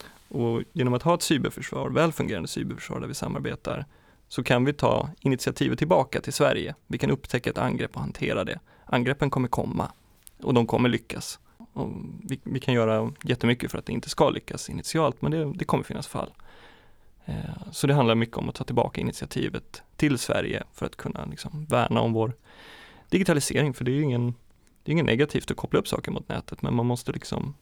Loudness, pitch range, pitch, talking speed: -27 LUFS, 120-145 Hz, 130 Hz, 185 wpm